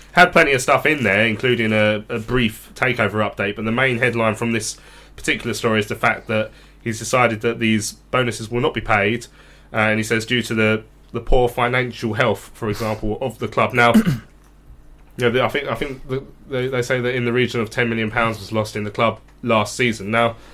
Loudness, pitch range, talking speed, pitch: -19 LUFS, 110-125 Hz, 220 wpm, 115 Hz